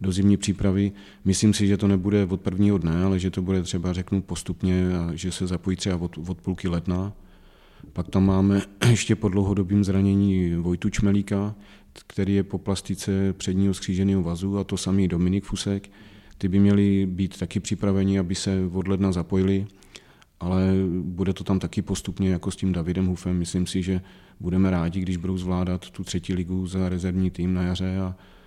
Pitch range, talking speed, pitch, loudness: 90-100 Hz, 180 wpm, 95 Hz, -24 LUFS